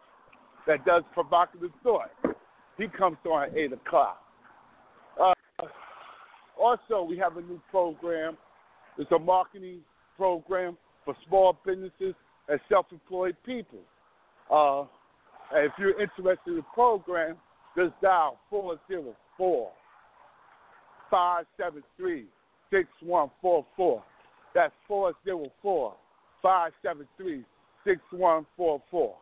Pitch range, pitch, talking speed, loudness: 170-200 Hz, 180 Hz, 90 wpm, -28 LUFS